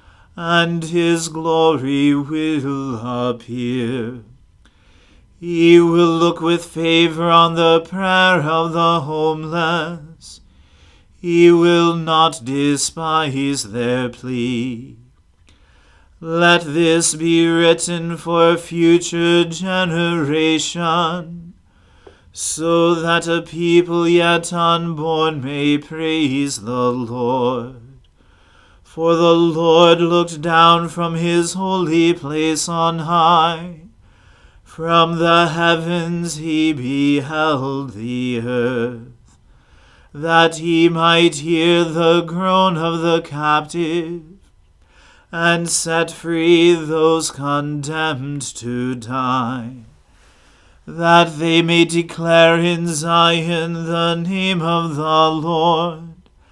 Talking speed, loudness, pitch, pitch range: 90 wpm, -16 LUFS, 165 Hz, 135-170 Hz